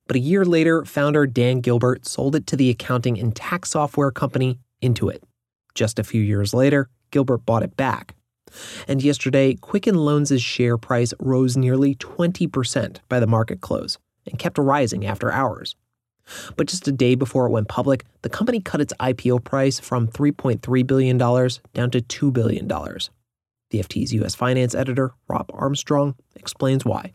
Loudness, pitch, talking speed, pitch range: -21 LUFS, 125 Hz, 165 wpm, 120-140 Hz